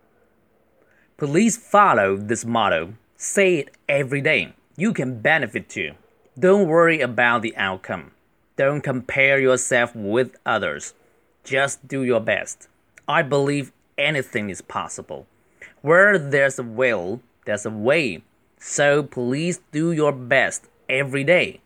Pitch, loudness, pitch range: 140 Hz, -20 LUFS, 125-165 Hz